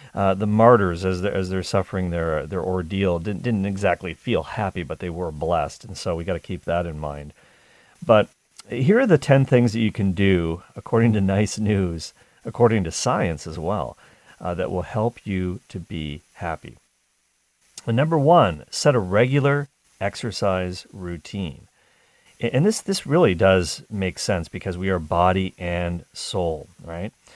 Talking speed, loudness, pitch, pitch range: 170 wpm, -22 LUFS, 95 Hz, 90-115 Hz